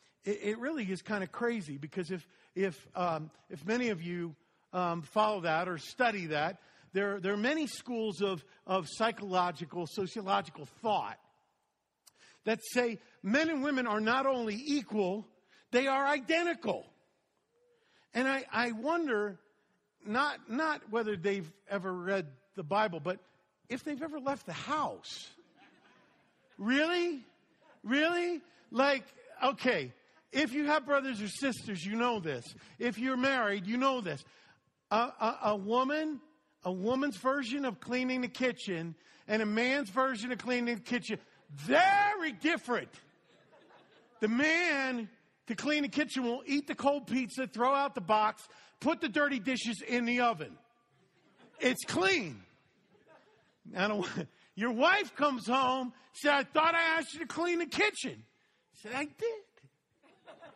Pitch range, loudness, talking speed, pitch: 205-285 Hz, -33 LUFS, 145 wpm, 245 Hz